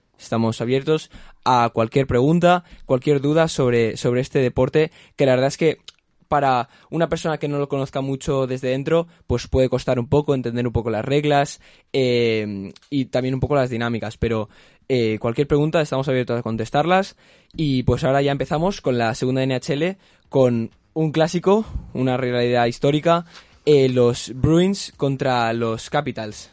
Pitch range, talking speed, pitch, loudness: 120-150 Hz, 165 wpm, 130 Hz, -20 LUFS